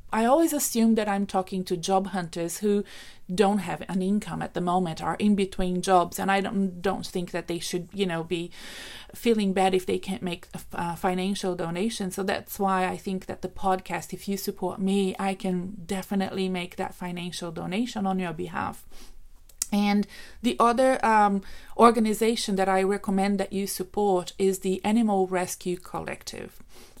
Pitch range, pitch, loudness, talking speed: 180-205 Hz, 190 Hz, -26 LUFS, 175 wpm